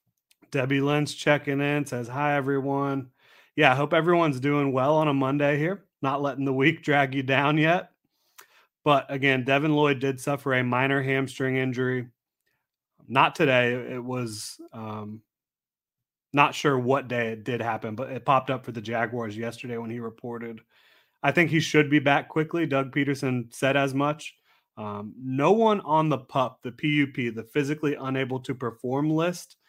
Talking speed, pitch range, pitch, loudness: 170 wpm, 125-145 Hz, 135 Hz, -25 LUFS